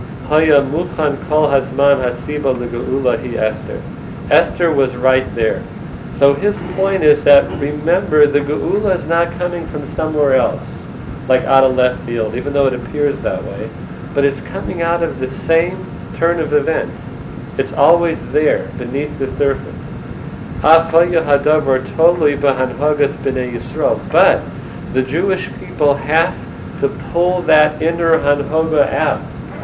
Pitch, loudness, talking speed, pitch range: 145 Hz, -16 LUFS, 125 wpm, 130-165 Hz